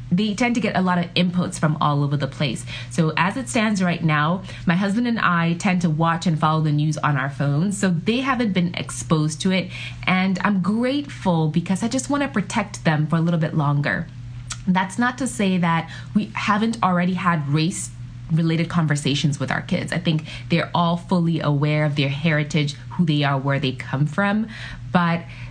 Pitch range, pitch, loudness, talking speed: 150-185 Hz, 165 Hz, -21 LUFS, 205 wpm